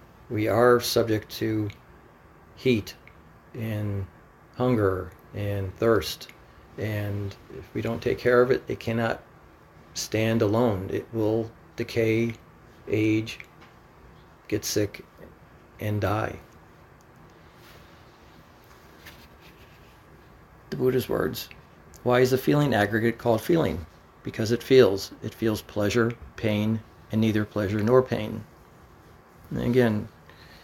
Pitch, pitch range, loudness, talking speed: 110 Hz, 100-115 Hz, -26 LUFS, 105 wpm